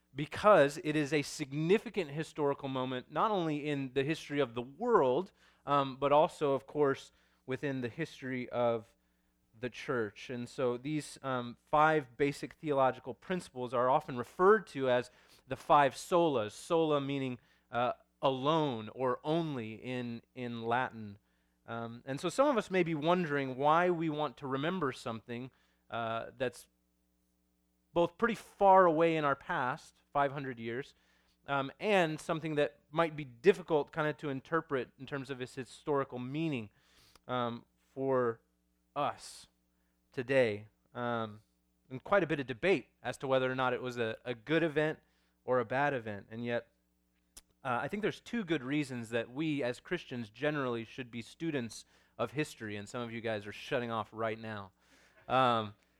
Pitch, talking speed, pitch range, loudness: 130 Hz, 160 wpm, 115-155 Hz, -34 LUFS